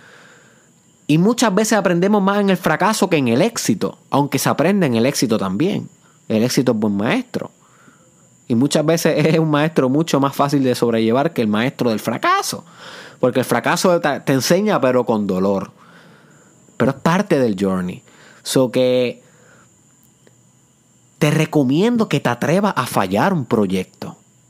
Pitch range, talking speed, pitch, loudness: 125-195 Hz, 155 wpm, 150 Hz, -17 LUFS